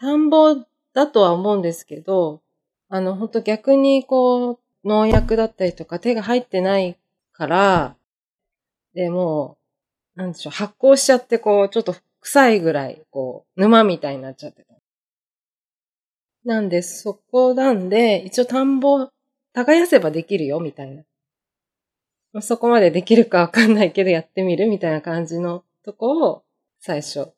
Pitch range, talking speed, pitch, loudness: 170-245 Hz, 295 characters per minute, 195 Hz, -18 LUFS